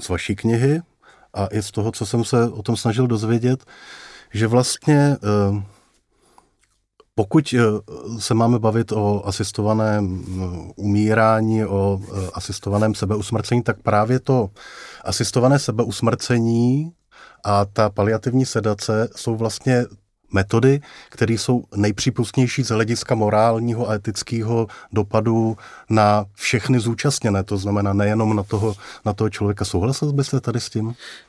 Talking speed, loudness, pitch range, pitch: 120 wpm, -20 LUFS, 105-120 Hz, 110 Hz